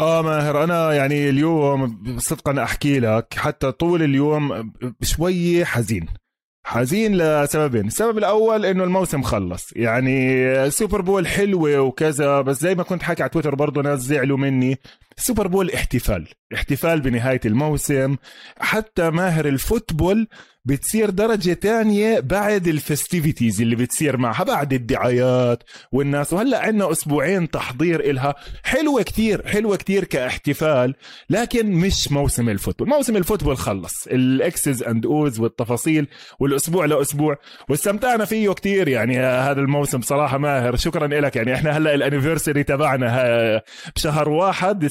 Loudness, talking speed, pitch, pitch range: -20 LUFS, 130 wpm, 145 Hz, 130-175 Hz